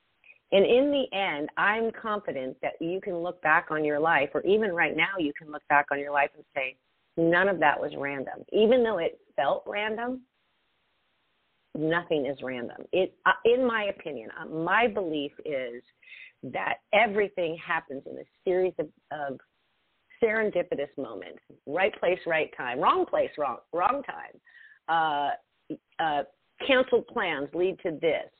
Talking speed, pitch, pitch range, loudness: 160 wpm, 180 Hz, 150-230 Hz, -27 LUFS